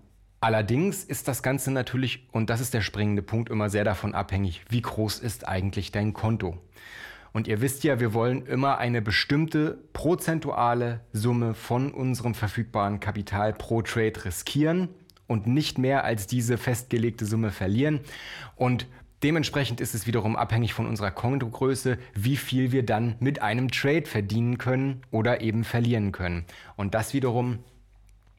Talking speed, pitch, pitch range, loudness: 150 wpm, 120 Hz, 105-130 Hz, -27 LUFS